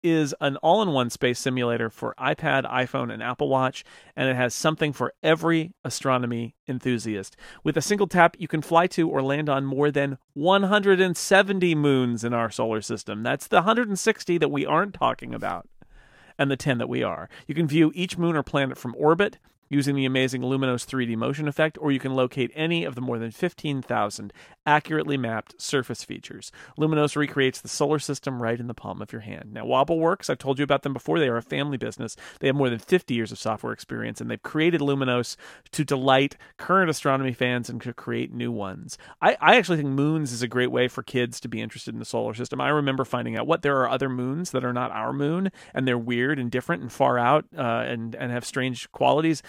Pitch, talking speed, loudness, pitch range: 135 Hz, 215 wpm, -24 LUFS, 125-155 Hz